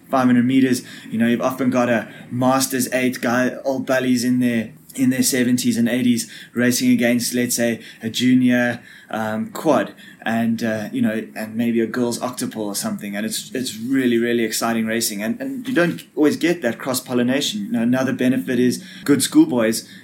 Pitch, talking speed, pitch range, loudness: 125 Hz, 185 wpm, 115-135 Hz, -20 LUFS